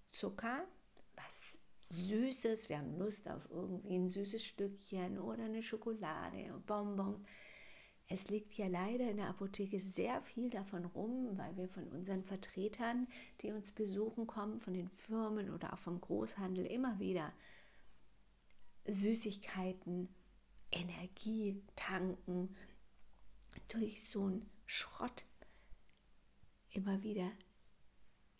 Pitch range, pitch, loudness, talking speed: 185-220 Hz, 200 Hz, -43 LUFS, 110 wpm